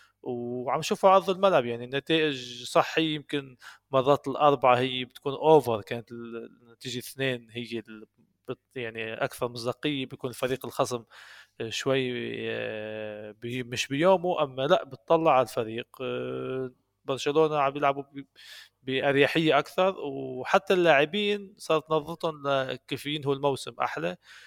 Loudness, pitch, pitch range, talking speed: -27 LUFS, 135 Hz, 120-150 Hz, 115 wpm